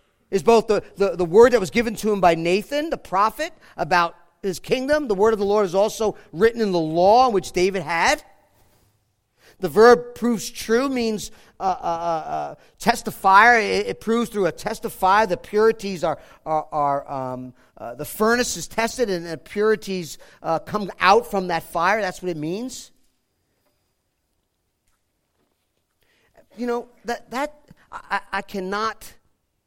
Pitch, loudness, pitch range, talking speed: 195 Hz, -21 LUFS, 170-225 Hz, 160 wpm